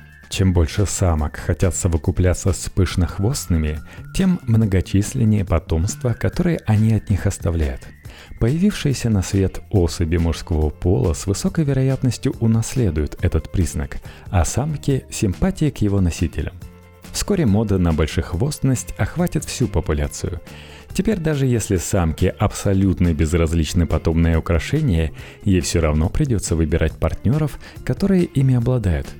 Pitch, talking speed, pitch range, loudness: 95 Hz, 115 wpm, 85-120 Hz, -20 LUFS